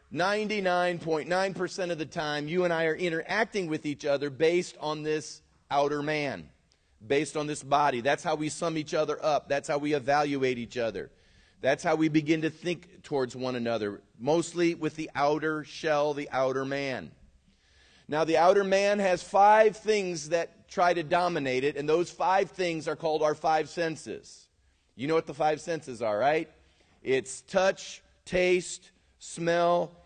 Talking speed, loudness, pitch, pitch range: 170 wpm, -28 LUFS, 155 Hz, 145-175 Hz